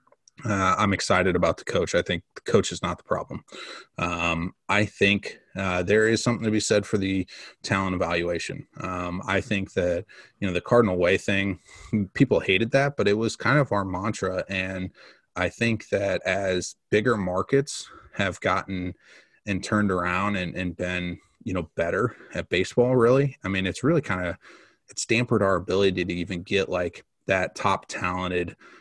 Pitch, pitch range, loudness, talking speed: 95 Hz, 90-110 Hz, -25 LUFS, 180 wpm